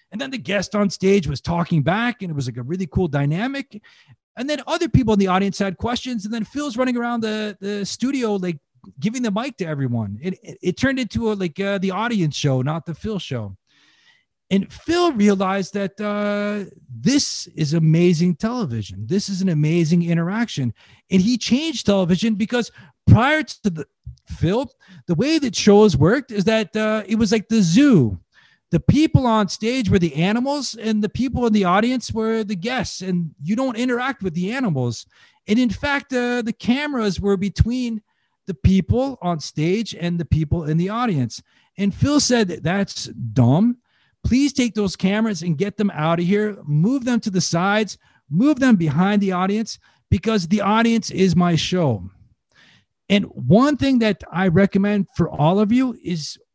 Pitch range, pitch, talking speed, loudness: 170-230 Hz, 200 Hz, 185 wpm, -20 LUFS